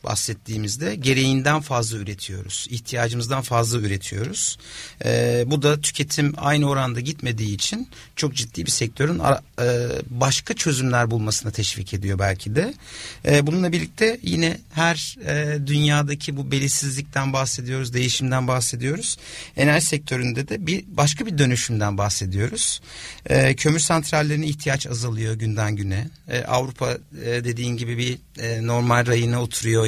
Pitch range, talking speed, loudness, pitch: 115-145 Hz, 130 wpm, -22 LUFS, 130 Hz